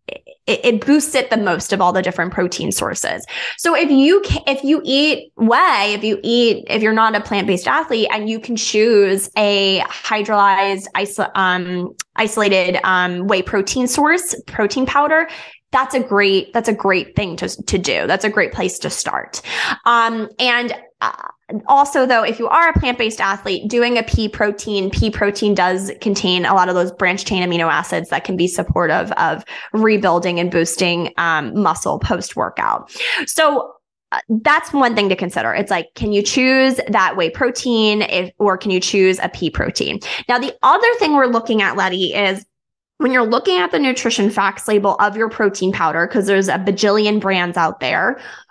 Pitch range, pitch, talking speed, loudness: 190-245 Hz, 210 Hz, 185 wpm, -16 LUFS